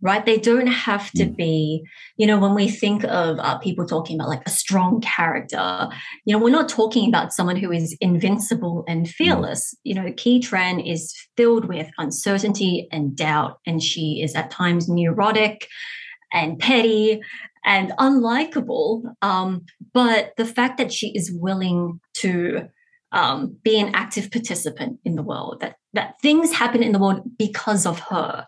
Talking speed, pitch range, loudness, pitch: 165 wpm, 175-230 Hz, -20 LUFS, 205 Hz